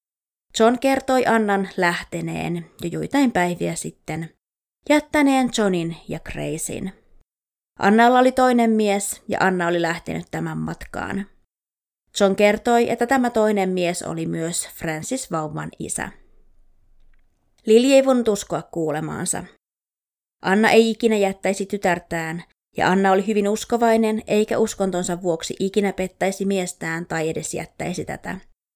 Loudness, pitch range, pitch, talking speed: -21 LUFS, 170-225 Hz, 195 Hz, 120 wpm